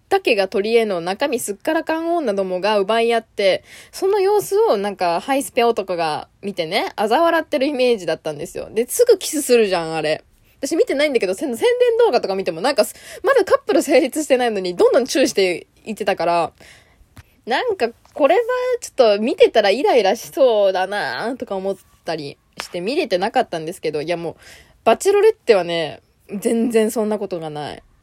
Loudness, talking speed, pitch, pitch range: -18 LUFS, 395 characters per minute, 230 Hz, 190-325 Hz